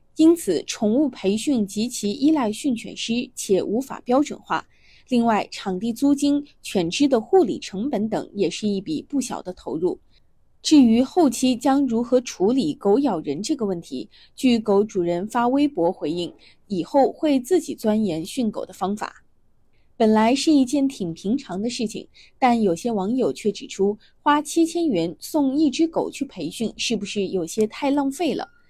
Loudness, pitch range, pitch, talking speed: -22 LUFS, 205-285 Hz, 240 Hz, 245 characters per minute